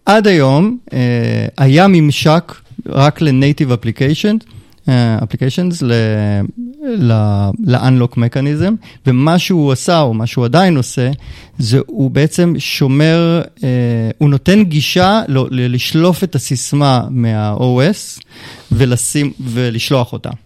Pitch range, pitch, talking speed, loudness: 120-160 Hz, 135 Hz, 100 wpm, -13 LUFS